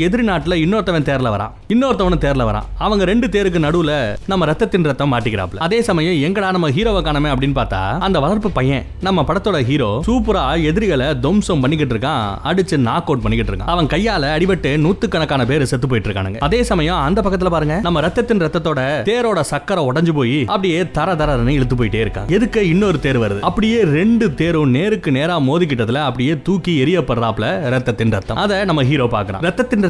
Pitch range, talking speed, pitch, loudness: 130-190 Hz, 75 wpm, 155 Hz, -16 LUFS